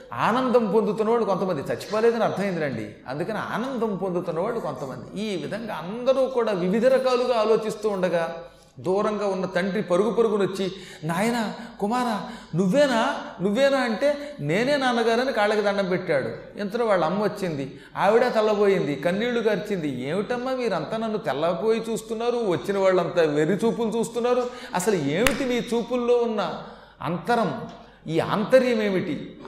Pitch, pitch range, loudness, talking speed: 215 Hz, 185-235 Hz, -24 LUFS, 120 wpm